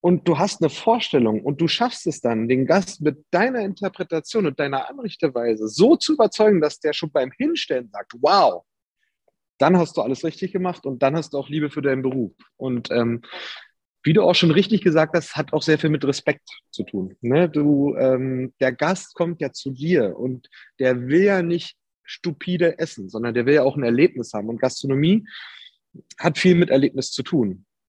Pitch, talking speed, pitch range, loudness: 155 Hz, 200 wpm, 130-180 Hz, -21 LUFS